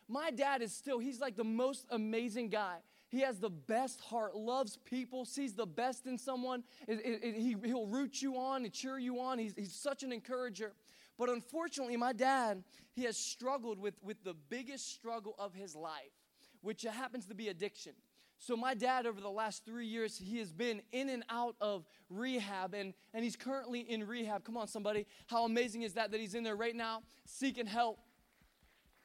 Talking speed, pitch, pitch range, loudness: 200 wpm, 235 Hz, 220-255 Hz, -40 LUFS